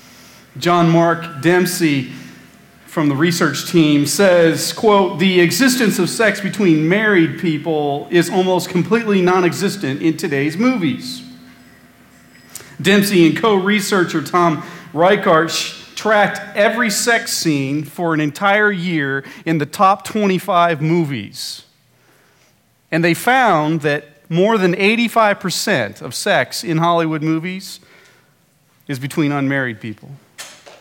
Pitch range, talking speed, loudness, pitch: 150-195 Hz, 110 wpm, -16 LUFS, 170 Hz